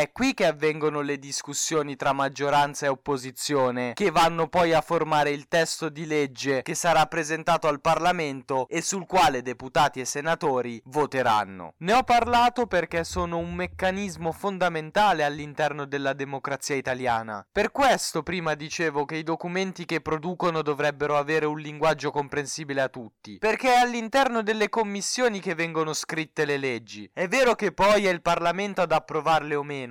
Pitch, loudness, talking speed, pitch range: 155 Hz, -25 LUFS, 160 wpm, 145-175 Hz